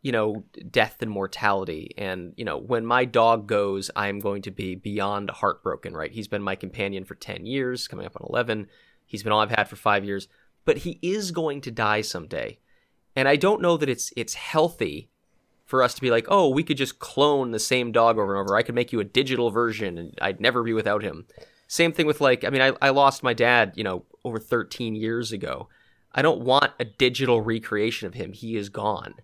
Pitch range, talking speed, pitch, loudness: 105-130 Hz, 230 wpm, 115 Hz, -24 LUFS